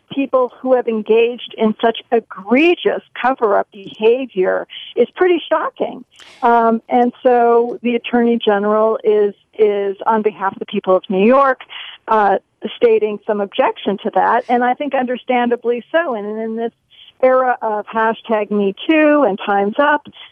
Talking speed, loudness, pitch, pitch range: 150 wpm, -16 LUFS, 230 Hz, 215-255 Hz